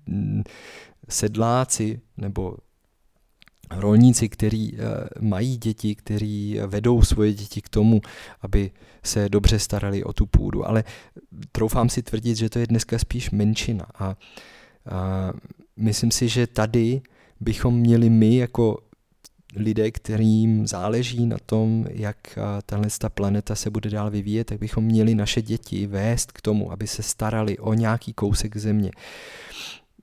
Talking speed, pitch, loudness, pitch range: 130 wpm, 110 Hz, -23 LUFS, 105-115 Hz